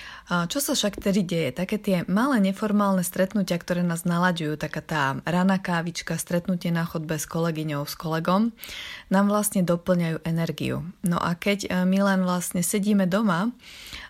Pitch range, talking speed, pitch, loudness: 165-200 Hz, 155 wpm, 180 Hz, -25 LUFS